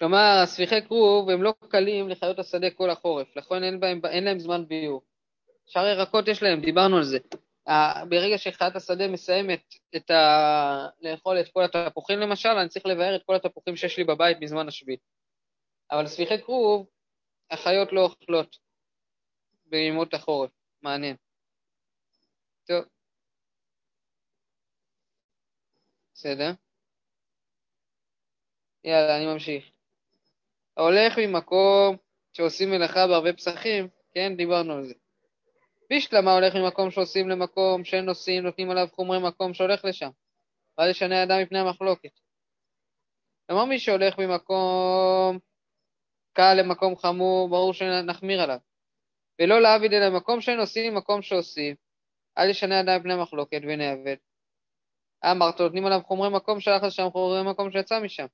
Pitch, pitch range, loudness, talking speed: 185 Hz, 170-195 Hz, -24 LUFS, 125 wpm